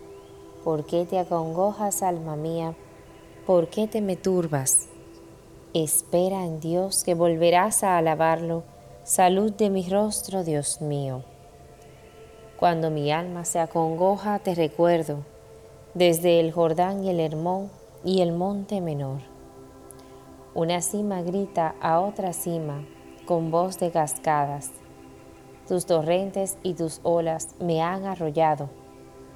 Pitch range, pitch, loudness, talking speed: 145-185 Hz, 165 Hz, -25 LUFS, 120 wpm